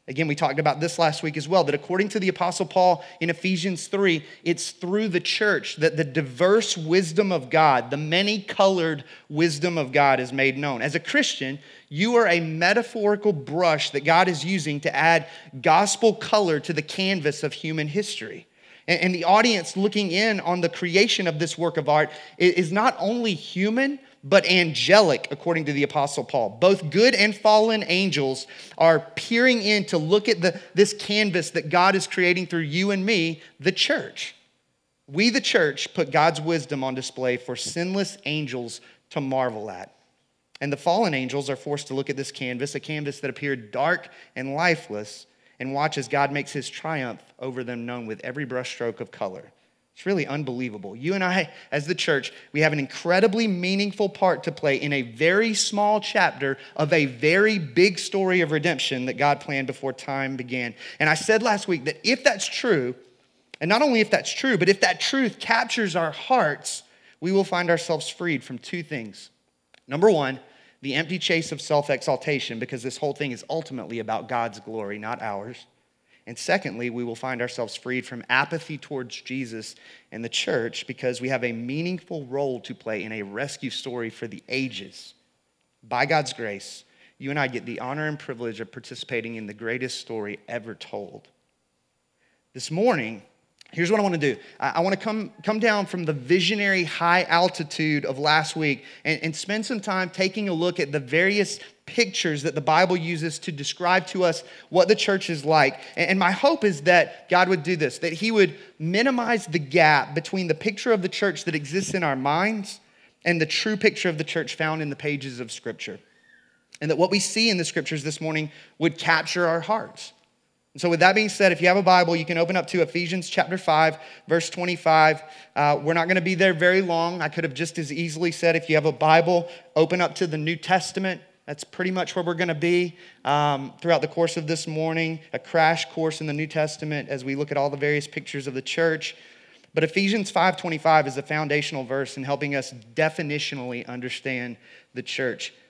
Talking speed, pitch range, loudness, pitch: 200 wpm, 140-185 Hz, -23 LUFS, 165 Hz